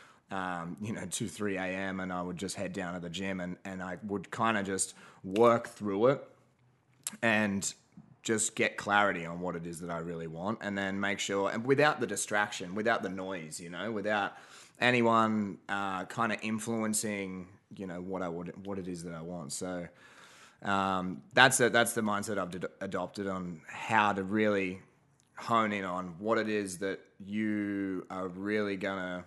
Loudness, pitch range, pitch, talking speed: -32 LUFS, 90-105 Hz, 100 Hz, 190 wpm